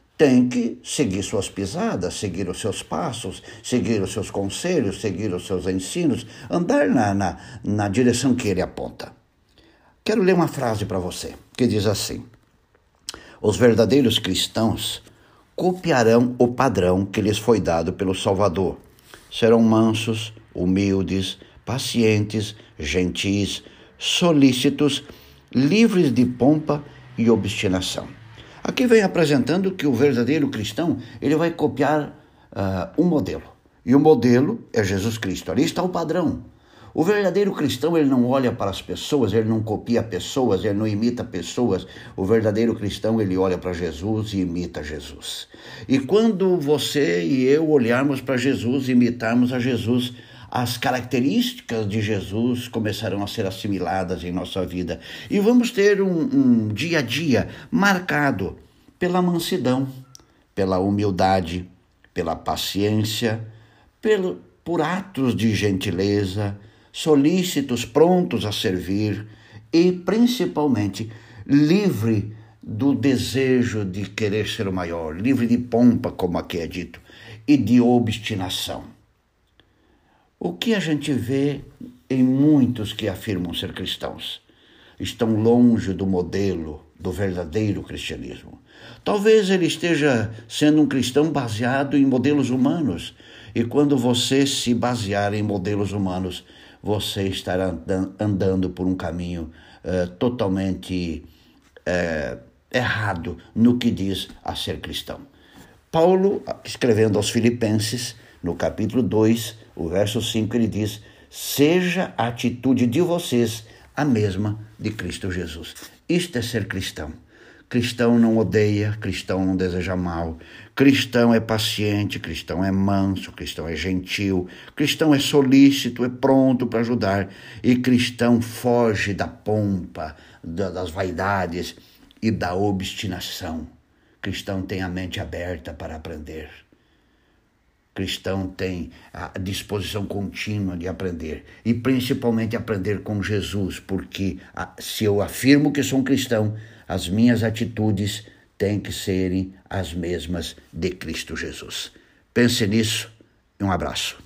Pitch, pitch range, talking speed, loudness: 110 Hz, 95-125 Hz, 130 wpm, -21 LUFS